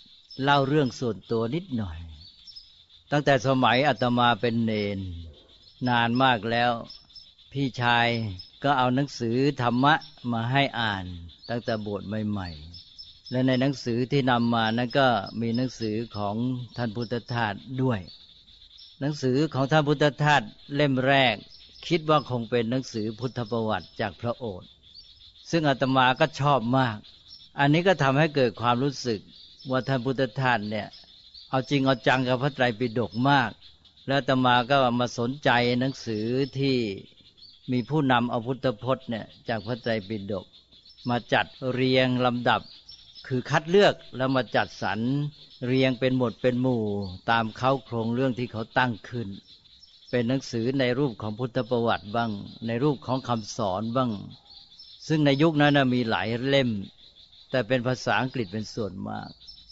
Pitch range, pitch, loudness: 110-130 Hz, 120 Hz, -25 LUFS